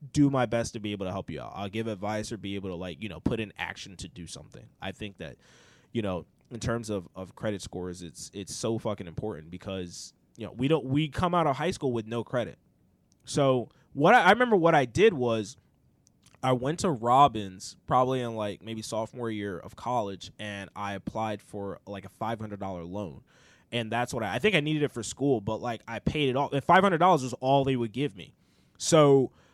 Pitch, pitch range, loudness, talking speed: 115 Hz, 100-130 Hz, -28 LUFS, 225 wpm